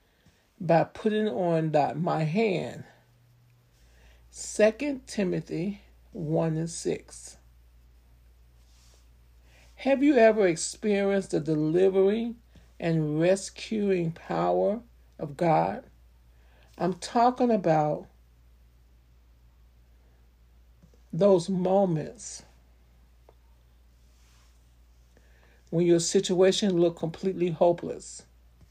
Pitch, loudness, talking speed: 120 Hz, -26 LUFS, 65 wpm